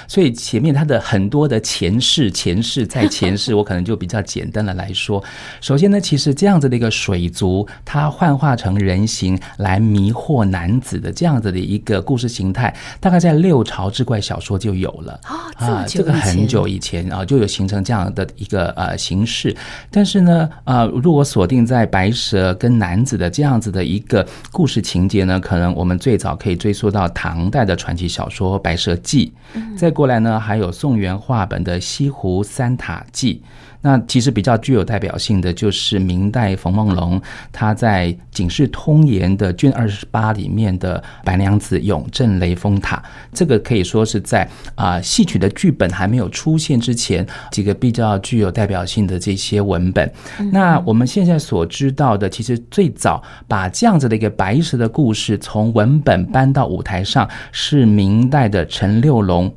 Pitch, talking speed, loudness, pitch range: 110 Hz, 275 characters per minute, -16 LUFS, 95-125 Hz